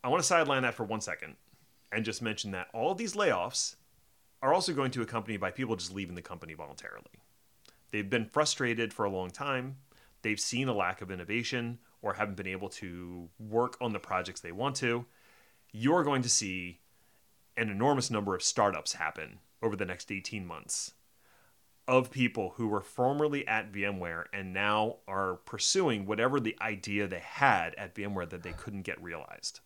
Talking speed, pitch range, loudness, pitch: 185 wpm, 95-120 Hz, -32 LUFS, 105 Hz